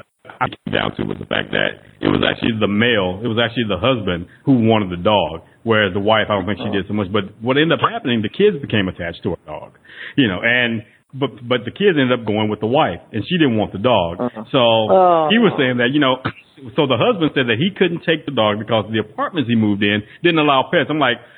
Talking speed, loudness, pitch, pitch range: 260 wpm, -17 LUFS, 120 Hz, 105-140 Hz